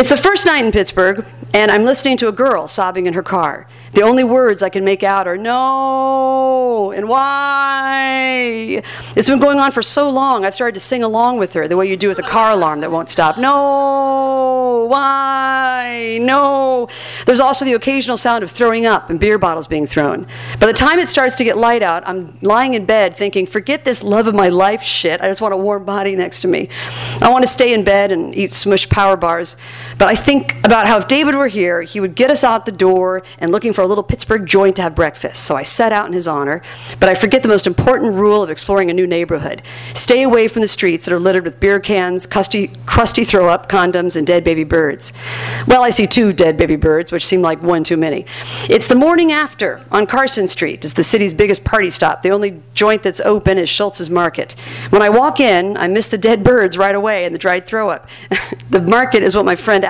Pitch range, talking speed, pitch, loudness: 185-250 Hz, 230 wpm, 205 Hz, -13 LUFS